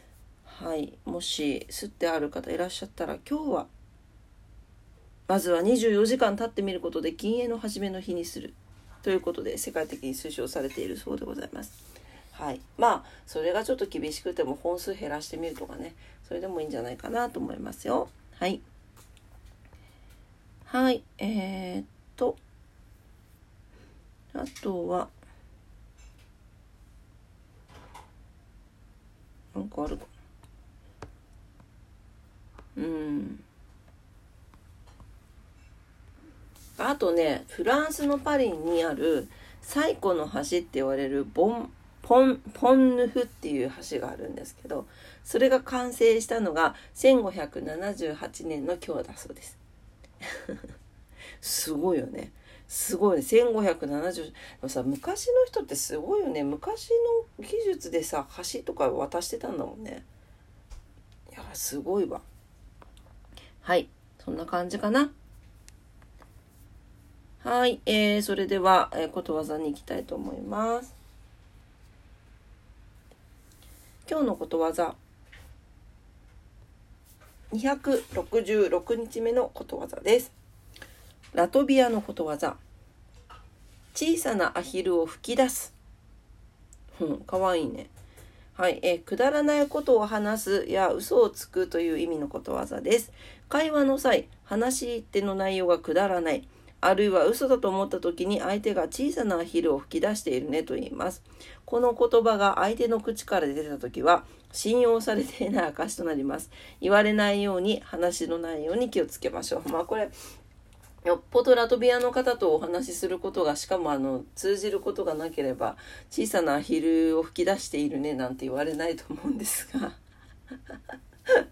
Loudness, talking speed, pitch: -28 LUFS, 255 characters per minute, 170 Hz